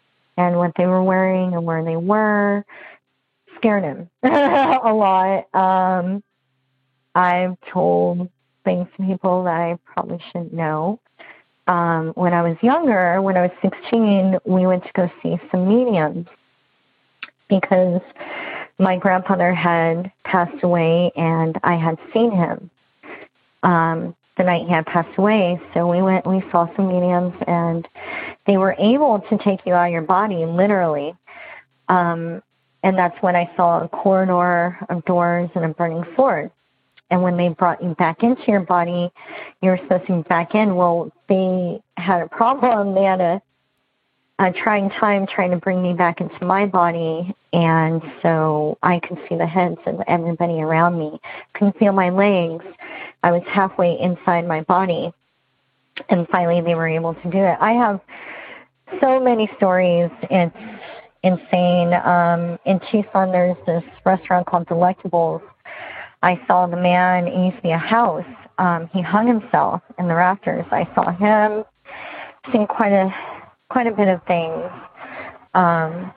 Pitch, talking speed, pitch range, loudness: 180 Hz, 160 wpm, 170-195 Hz, -18 LUFS